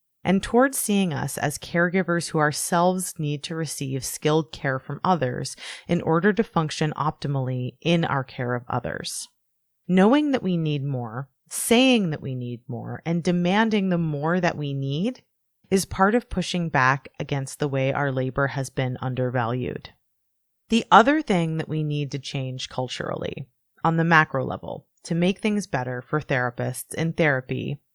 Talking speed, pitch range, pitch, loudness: 165 wpm, 130-175 Hz, 150 Hz, -24 LUFS